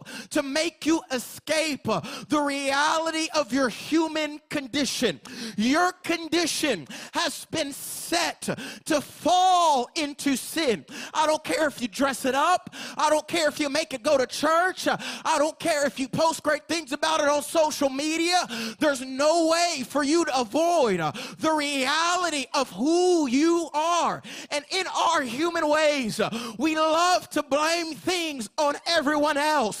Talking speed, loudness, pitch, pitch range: 155 wpm, -25 LUFS, 300 Hz, 280-320 Hz